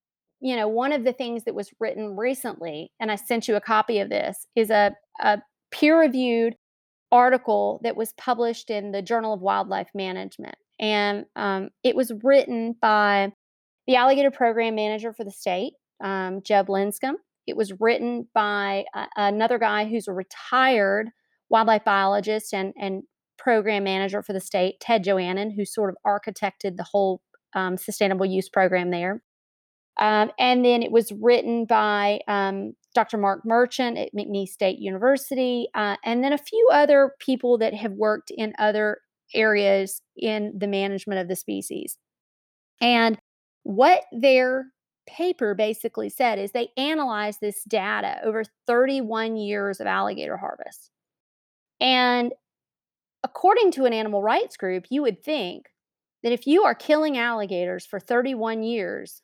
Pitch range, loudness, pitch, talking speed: 200-245 Hz, -23 LUFS, 220 Hz, 150 wpm